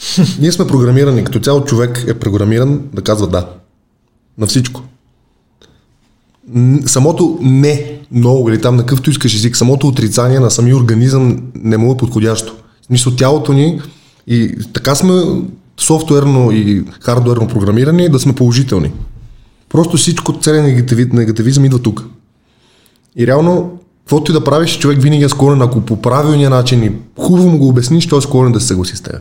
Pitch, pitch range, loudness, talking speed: 125 Hz, 115-145 Hz, -11 LUFS, 160 wpm